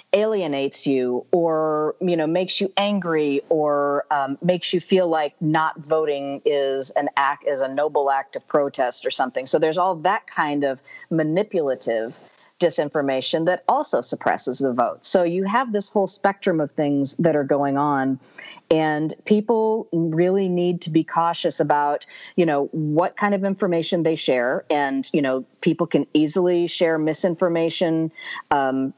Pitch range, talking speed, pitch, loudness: 145-180 Hz, 160 wpm, 160 Hz, -21 LUFS